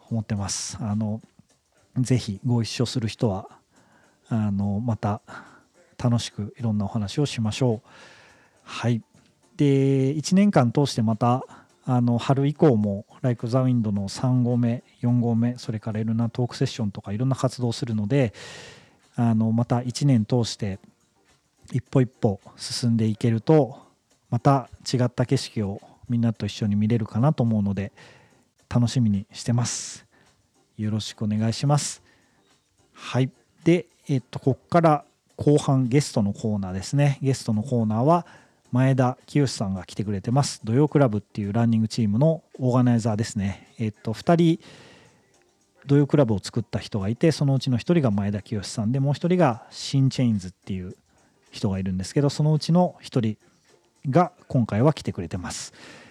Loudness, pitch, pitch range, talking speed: -24 LUFS, 120 Hz, 110-135 Hz, 325 characters per minute